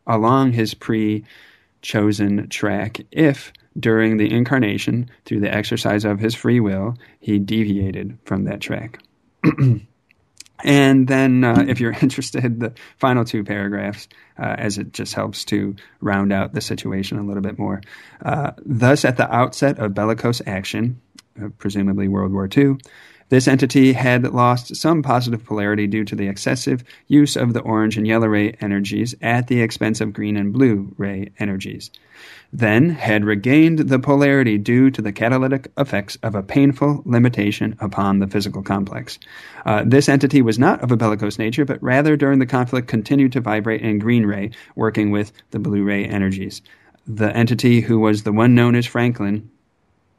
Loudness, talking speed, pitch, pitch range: -18 LUFS, 165 wpm, 110 Hz, 105-130 Hz